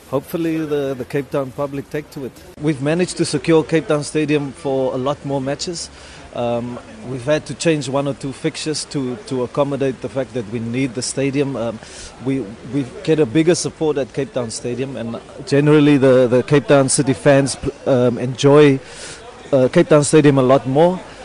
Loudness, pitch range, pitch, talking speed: -17 LUFS, 130-150 Hz, 140 Hz, 190 wpm